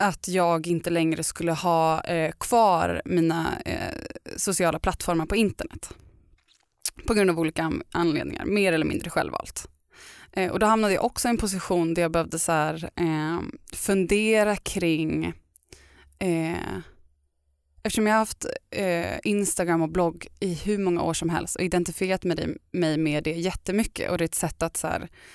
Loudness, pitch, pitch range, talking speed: -25 LUFS, 170 Hz, 160-195 Hz, 165 wpm